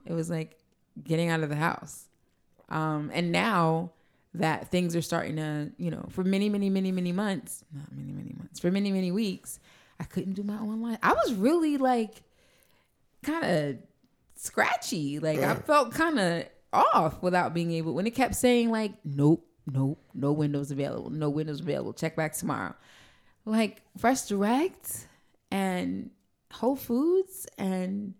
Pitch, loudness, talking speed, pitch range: 180 Hz, -28 LUFS, 160 wpm, 155-220 Hz